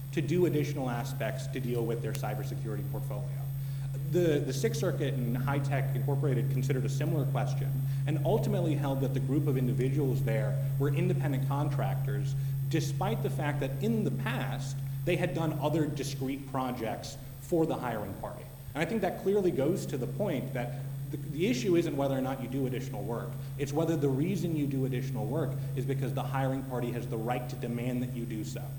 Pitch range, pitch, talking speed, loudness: 135-145 Hz, 135 Hz, 195 wpm, -32 LUFS